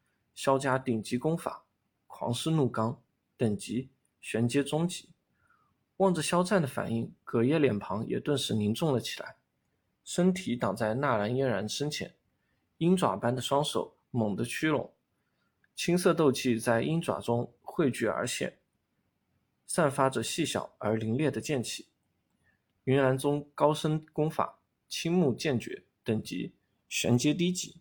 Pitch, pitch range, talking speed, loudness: 135 Hz, 115-155 Hz, 205 characters per minute, -30 LUFS